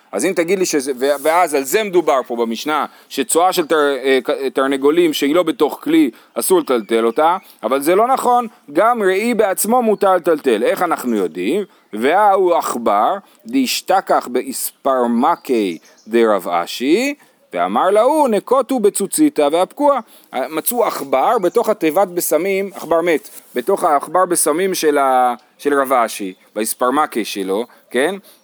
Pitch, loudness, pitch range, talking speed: 175 Hz, -16 LUFS, 140-220 Hz, 135 wpm